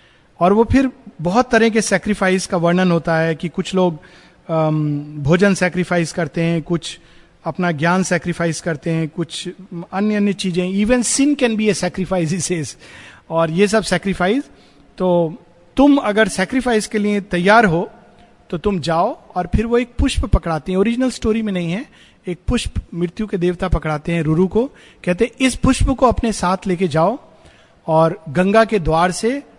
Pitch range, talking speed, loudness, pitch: 170-215 Hz, 170 wpm, -17 LUFS, 180 Hz